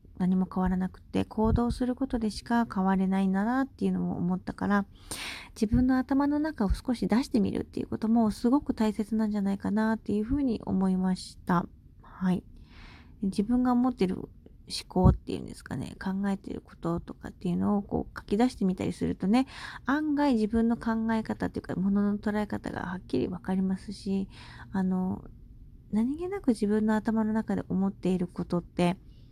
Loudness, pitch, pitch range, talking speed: -29 LUFS, 205 Hz, 185-235 Hz, 375 characters per minute